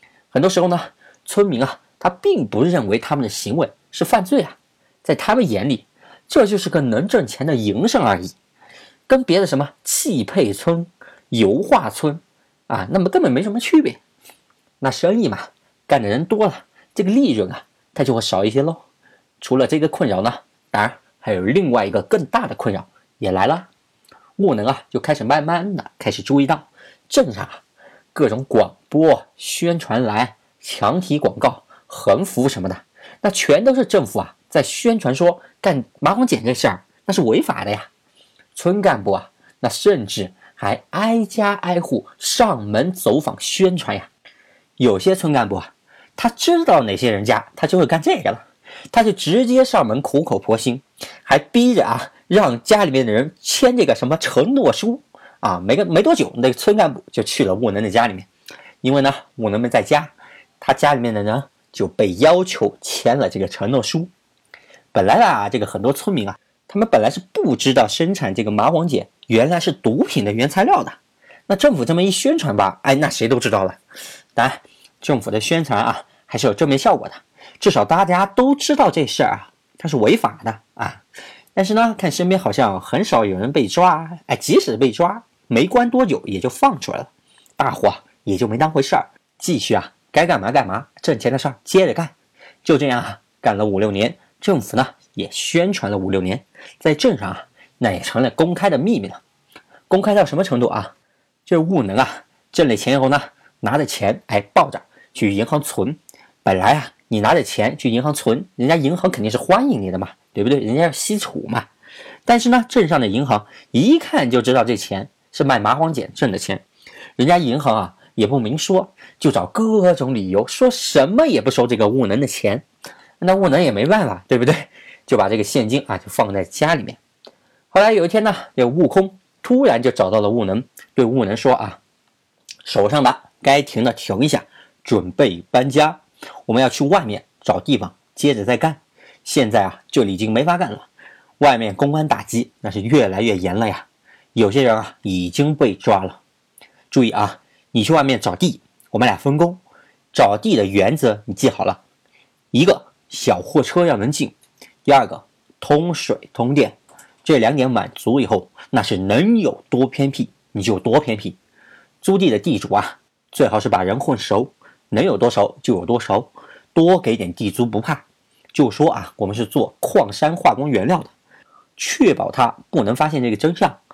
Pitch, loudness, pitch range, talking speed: 155 Hz, -18 LUFS, 120-195 Hz, 265 characters per minute